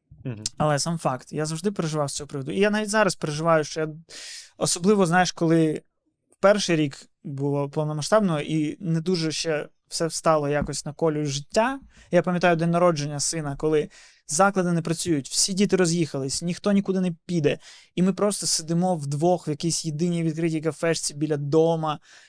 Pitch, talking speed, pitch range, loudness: 165 Hz, 165 wpm, 150-180 Hz, -24 LUFS